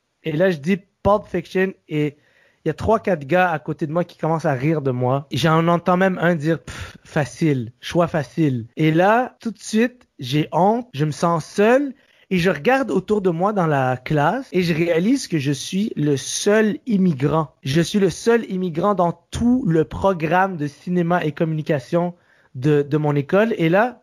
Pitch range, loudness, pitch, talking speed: 155-195 Hz, -20 LUFS, 170 Hz, 200 wpm